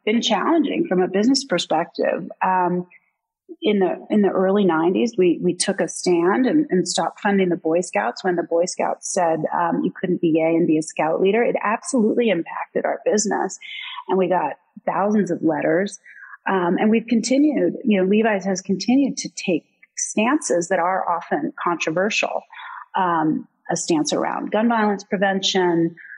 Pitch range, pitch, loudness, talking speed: 180-255 Hz, 200 Hz, -20 LUFS, 170 wpm